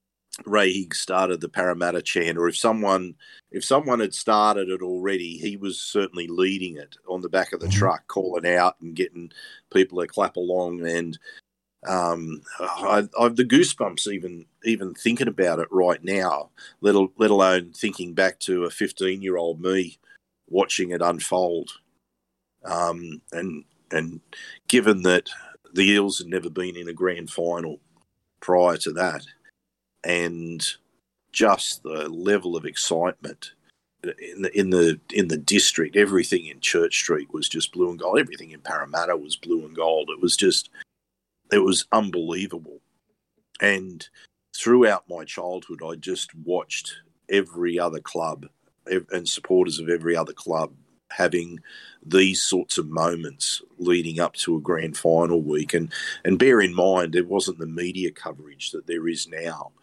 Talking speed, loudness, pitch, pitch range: 155 wpm, -23 LUFS, 90 Hz, 85-100 Hz